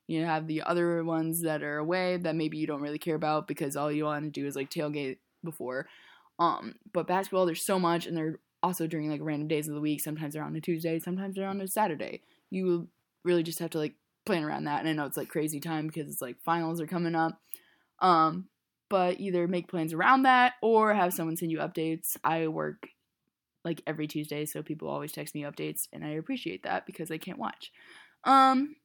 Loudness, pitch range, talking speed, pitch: -30 LUFS, 155-180 Hz, 225 wpm, 160 Hz